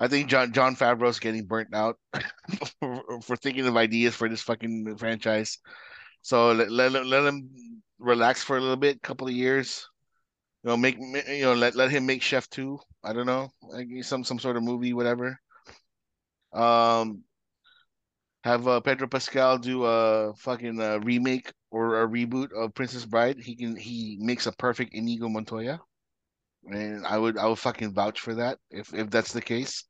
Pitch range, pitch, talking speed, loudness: 115-130 Hz, 120 Hz, 180 wpm, -26 LUFS